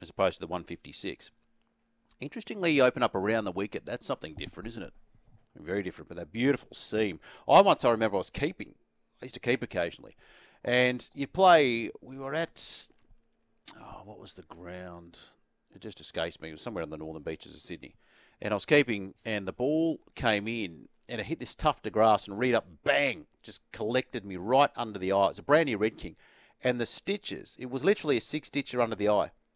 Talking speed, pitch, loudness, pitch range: 210 wpm, 110 Hz, -29 LUFS, 95-135 Hz